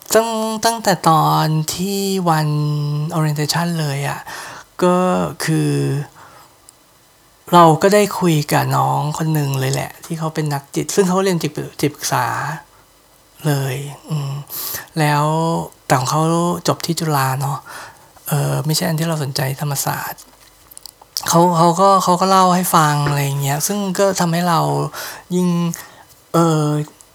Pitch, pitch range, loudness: 155 Hz, 145-175 Hz, -17 LUFS